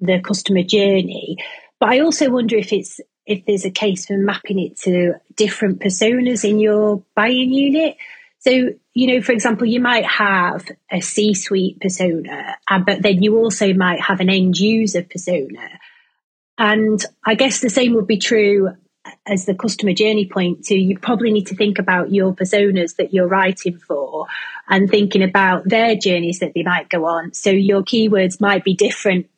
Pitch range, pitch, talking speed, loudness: 190-220 Hz, 200 Hz, 180 wpm, -16 LUFS